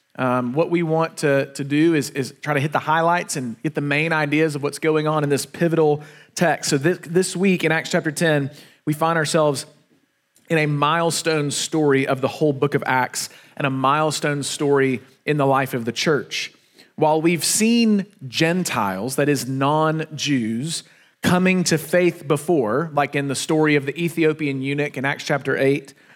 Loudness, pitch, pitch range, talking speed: -20 LUFS, 150 Hz, 140-160 Hz, 190 wpm